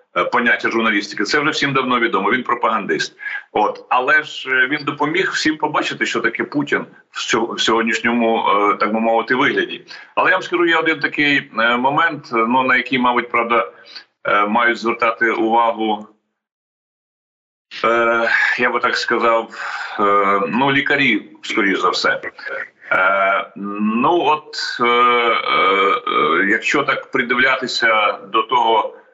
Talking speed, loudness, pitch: 115 wpm, -16 LUFS, 130 Hz